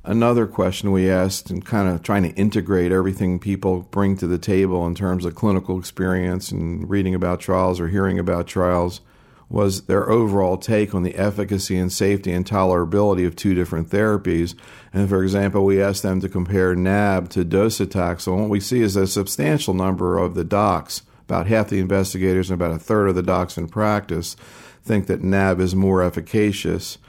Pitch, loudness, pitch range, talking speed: 95 Hz, -20 LUFS, 90-100 Hz, 185 wpm